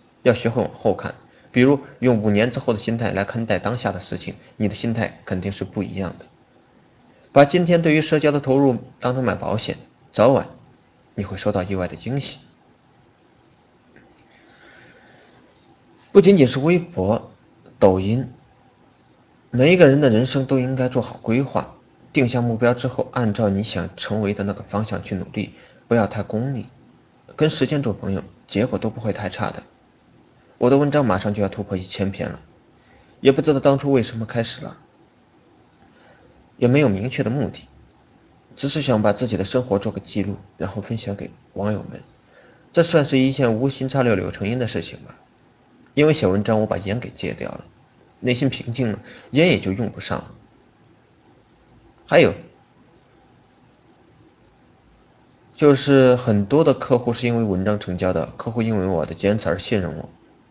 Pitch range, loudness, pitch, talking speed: 100-130 Hz, -20 LUFS, 115 Hz, 245 characters per minute